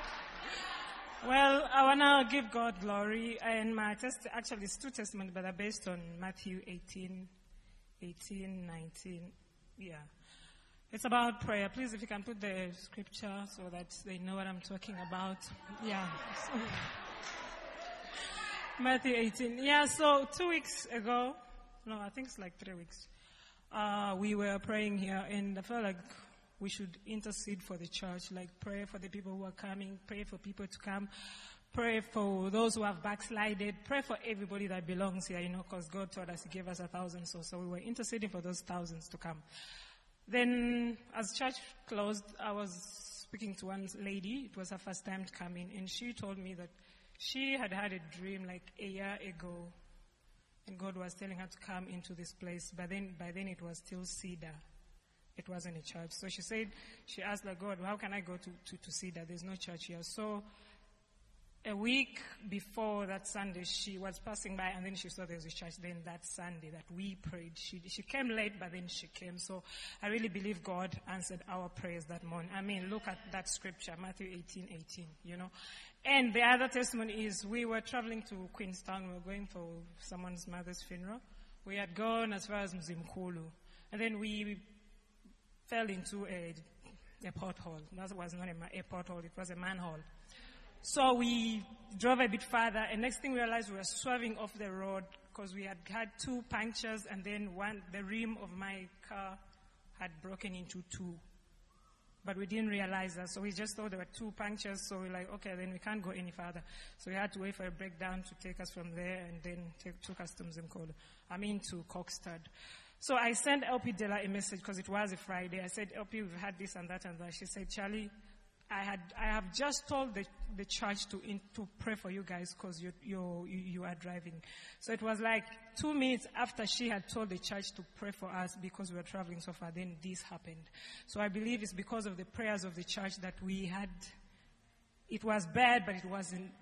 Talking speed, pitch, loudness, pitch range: 200 wpm, 195 Hz, -39 LUFS, 180-215 Hz